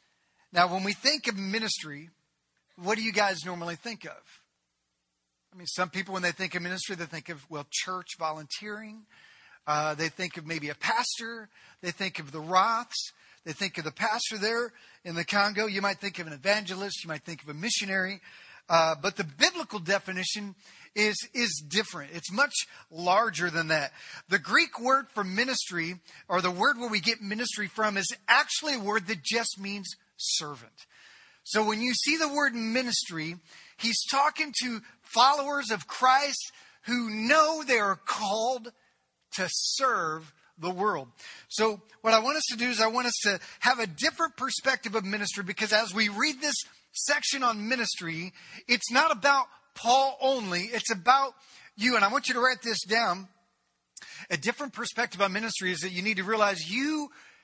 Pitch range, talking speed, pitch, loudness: 180-240 Hz, 180 wpm, 210 Hz, -27 LUFS